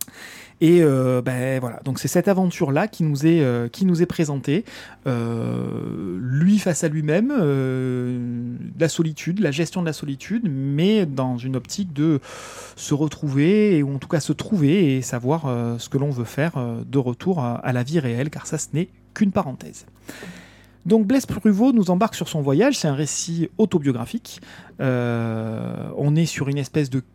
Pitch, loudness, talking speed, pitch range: 150 Hz, -21 LUFS, 185 wpm, 125-175 Hz